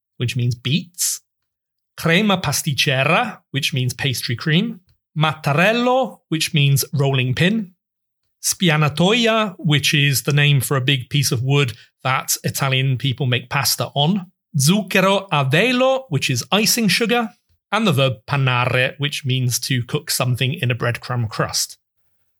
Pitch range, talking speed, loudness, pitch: 130-180 Hz, 135 wpm, -18 LUFS, 145 Hz